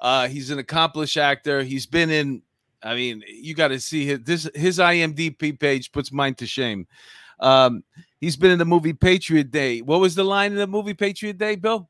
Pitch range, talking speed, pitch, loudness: 135-175 Hz, 205 wpm, 155 Hz, -21 LUFS